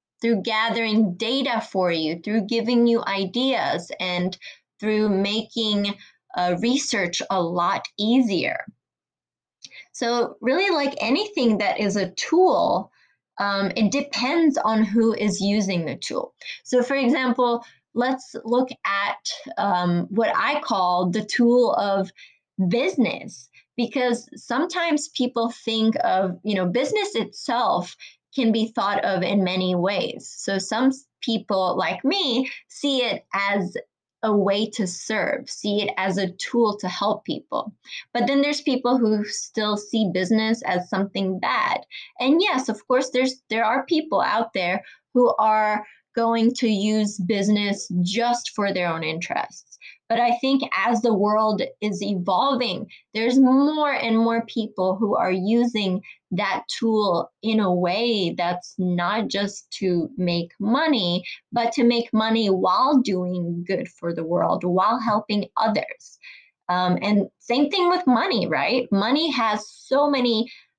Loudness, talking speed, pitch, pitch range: -22 LUFS, 140 wpm, 220 Hz, 195-250 Hz